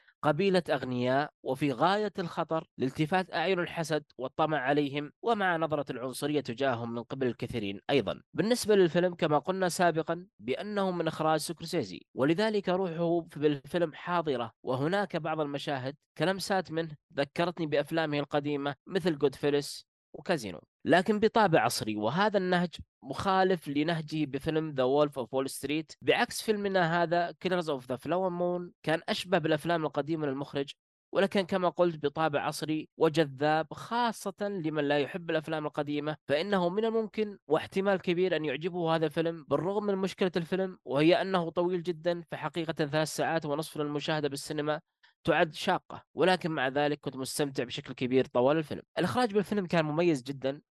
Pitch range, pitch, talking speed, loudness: 145-180 Hz, 160 Hz, 140 wpm, -30 LUFS